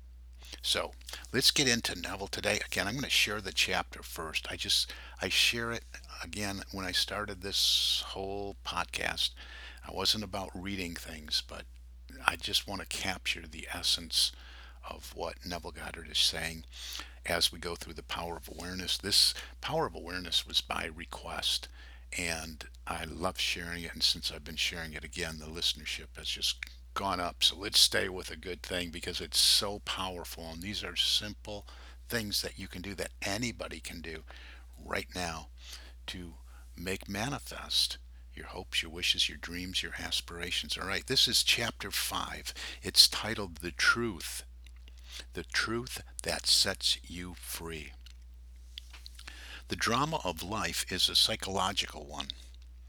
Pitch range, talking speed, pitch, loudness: 60-90 Hz, 160 wpm, 80 Hz, -31 LUFS